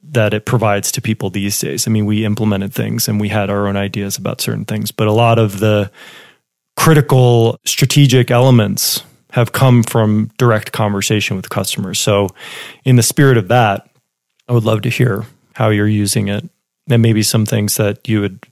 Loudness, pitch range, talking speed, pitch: -14 LUFS, 105-120 Hz, 190 wpm, 110 Hz